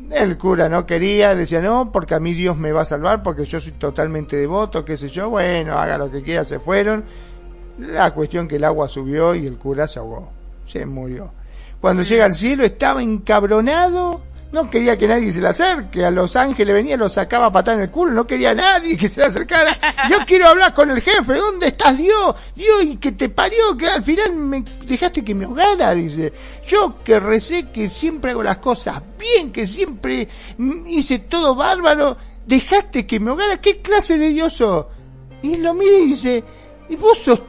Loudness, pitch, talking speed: -16 LUFS, 230 Hz, 205 wpm